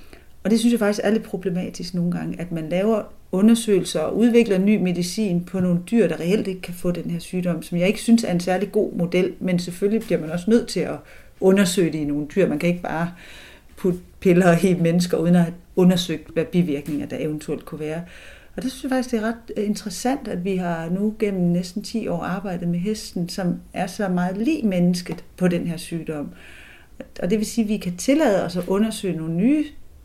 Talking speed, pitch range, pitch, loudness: 220 wpm, 175-215 Hz, 185 Hz, -22 LUFS